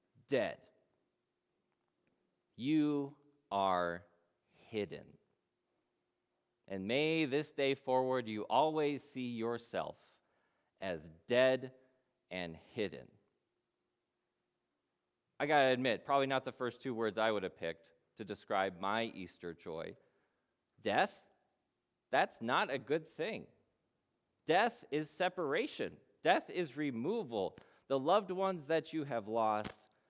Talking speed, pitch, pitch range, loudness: 110 wpm, 120 Hz, 90-145 Hz, -36 LUFS